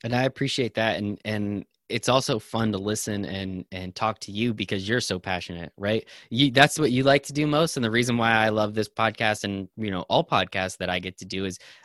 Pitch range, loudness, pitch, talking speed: 95-120 Hz, -25 LUFS, 110 Hz, 245 wpm